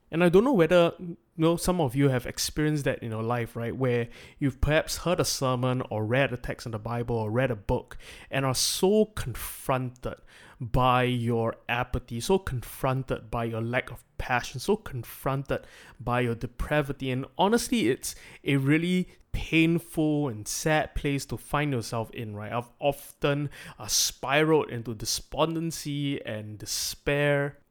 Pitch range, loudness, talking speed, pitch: 120-150 Hz, -27 LUFS, 160 wpm, 130 Hz